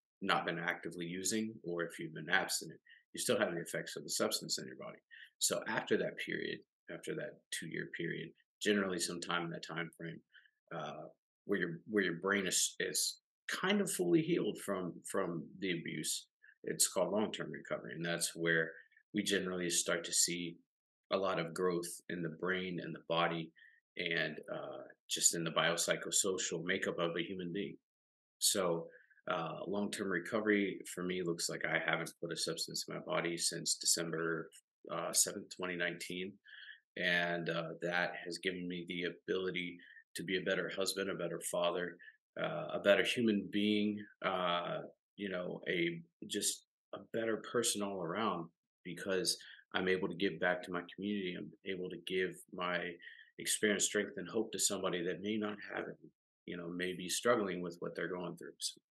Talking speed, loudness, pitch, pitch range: 175 wpm, -37 LUFS, 90 Hz, 85-100 Hz